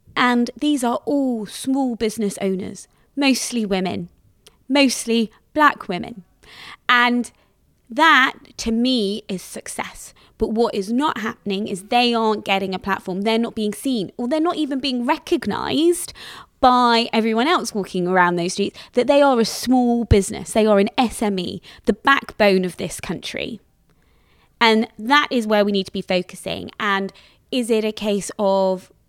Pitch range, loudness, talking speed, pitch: 200-255 Hz, -19 LUFS, 155 wpm, 225 Hz